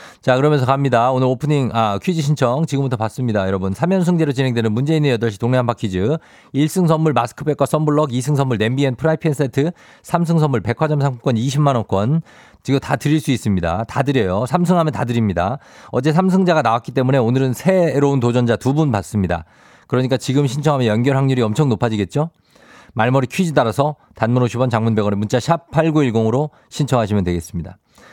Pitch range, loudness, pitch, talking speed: 115-150 Hz, -18 LUFS, 135 Hz, 390 characters per minute